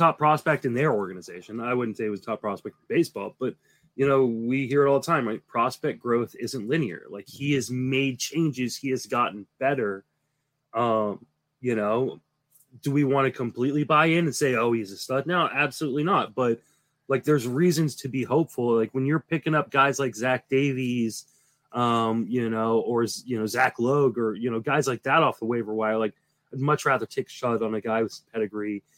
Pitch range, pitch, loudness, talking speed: 115-145 Hz, 130 Hz, -25 LUFS, 210 wpm